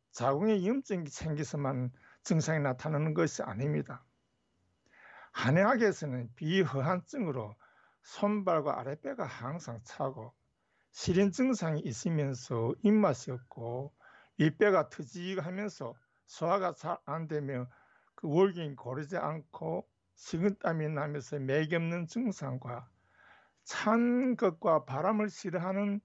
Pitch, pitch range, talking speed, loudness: 155 Hz, 135-195 Hz, 250 characters per minute, -33 LUFS